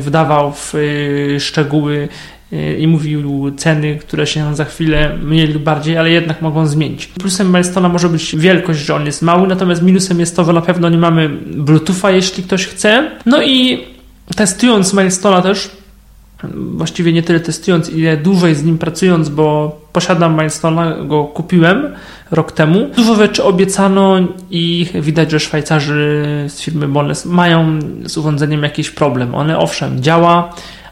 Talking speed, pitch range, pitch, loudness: 150 wpm, 150-180 Hz, 165 Hz, -13 LUFS